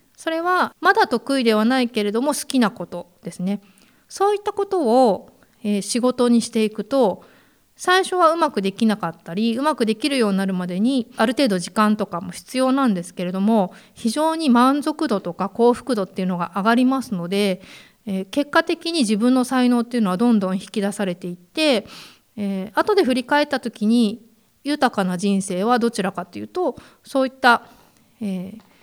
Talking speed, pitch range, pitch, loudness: 350 characters per minute, 195-265 Hz, 230 Hz, -20 LUFS